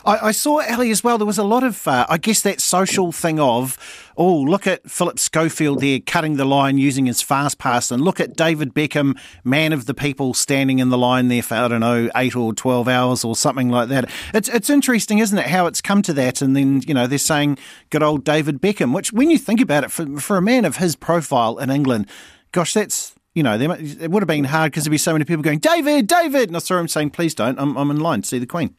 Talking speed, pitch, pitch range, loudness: 265 wpm, 155 Hz, 135-195 Hz, -18 LUFS